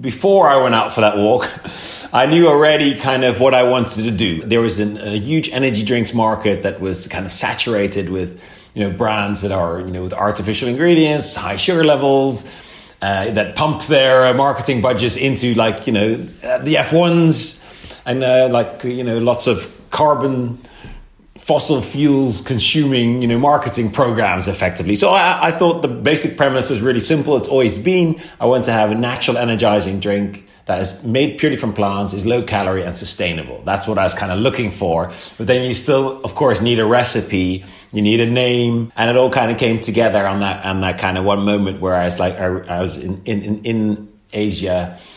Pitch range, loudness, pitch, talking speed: 100-135 Hz, -16 LUFS, 115 Hz, 205 wpm